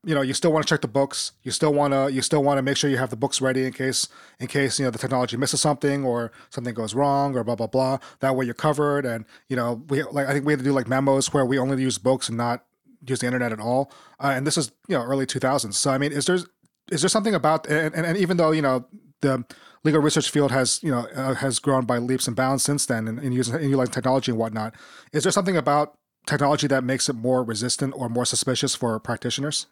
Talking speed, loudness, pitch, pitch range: 265 wpm, -23 LUFS, 135 Hz, 125-145 Hz